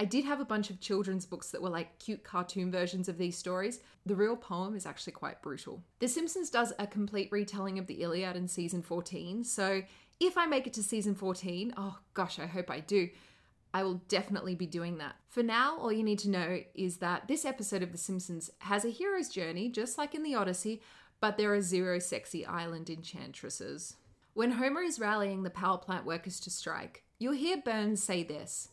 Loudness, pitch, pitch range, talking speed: -35 LUFS, 195 Hz, 180-220 Hz, 210 wpm